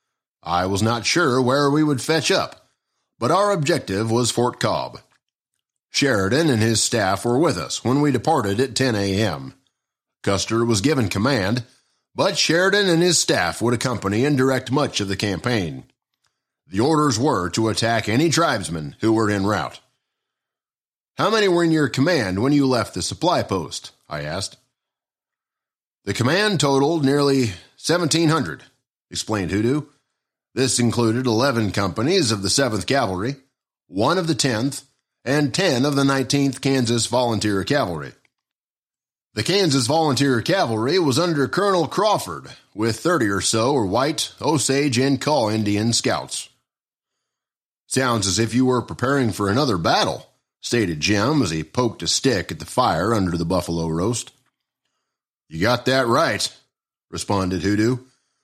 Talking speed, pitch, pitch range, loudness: 150 wpm, 125 Hz, 110-145 Hz, -20 LUFS